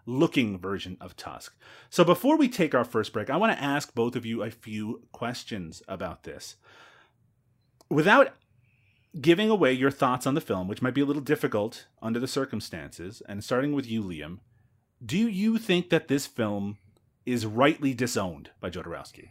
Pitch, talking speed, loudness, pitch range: 125 Hz, 175 wpm, -27 LUFS, 110-145 Hz